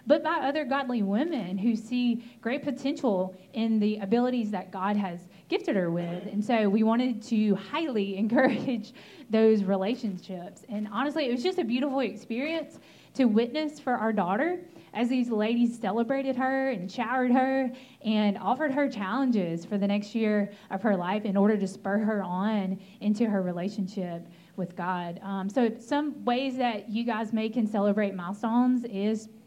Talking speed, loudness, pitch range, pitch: 165 wpm, -28 LUFS, 200-255 Hz, 220 Hz